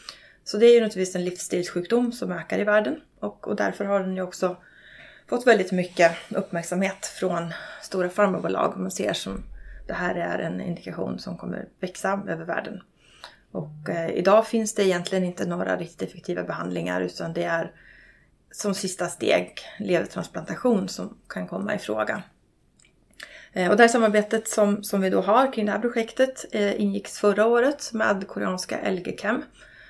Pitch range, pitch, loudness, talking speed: 180-215 Hz, 195 Hz, -25 LUFS, 170 wpm